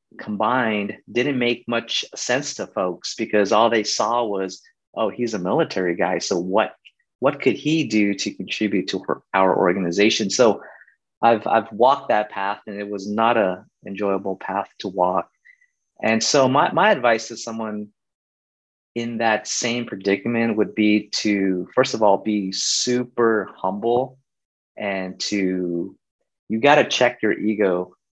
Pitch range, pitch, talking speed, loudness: 100-115 Hz, 110 Hz, 155 wpm, -21 LUFS